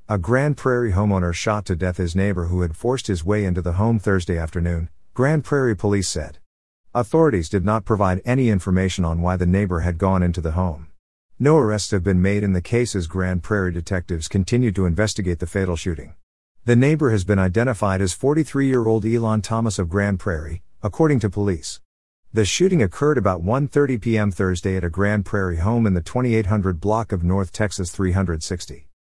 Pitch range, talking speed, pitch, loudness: 90-110 Hz, 185 wpm, 100 Hz, -21 LUFS